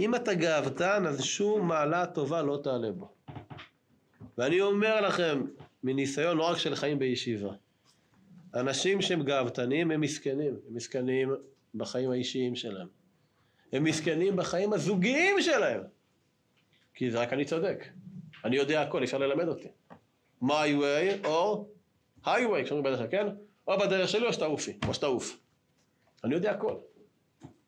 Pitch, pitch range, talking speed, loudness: 155 Hz, 130-195 Hz, 140 wpm, -30 LUFS